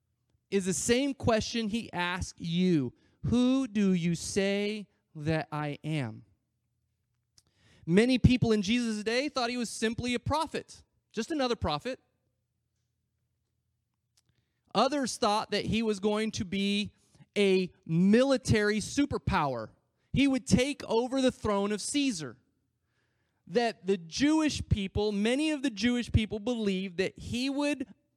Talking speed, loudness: 130 wpm, -29 LUFS